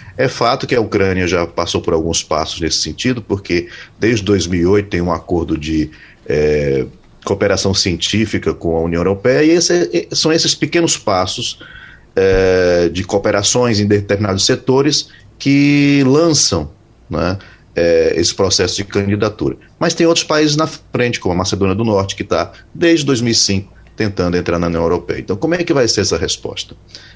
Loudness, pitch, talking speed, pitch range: -15 LUFS, 100 Hz, 165 wpm, 90-125 Hz